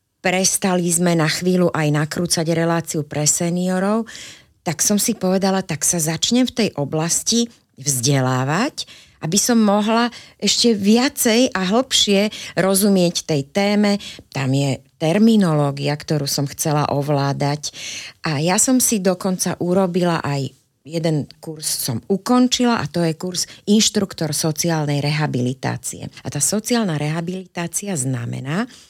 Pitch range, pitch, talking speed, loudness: 150-205 Hz, 170 Hz, 125 wpm, -18 LUFS